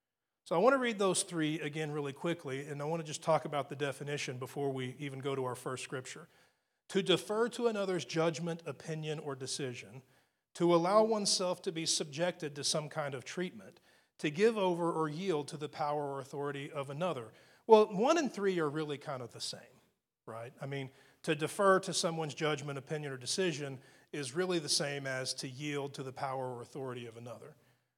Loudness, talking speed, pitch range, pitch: -34 LUFS, 200 wpm, 140-175 Hz, 150 Hz